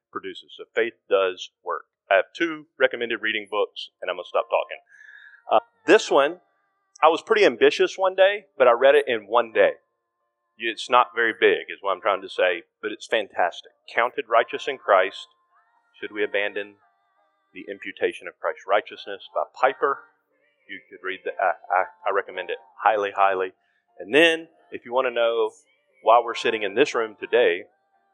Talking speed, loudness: 180 wpm, -23 LUFS